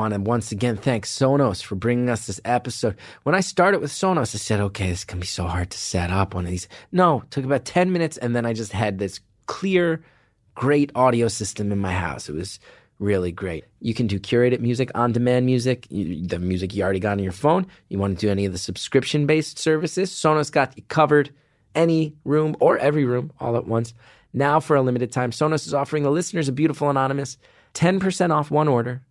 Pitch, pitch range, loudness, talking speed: 125 Hz, 100-150 Hz, -22 LUFS, 220 wpm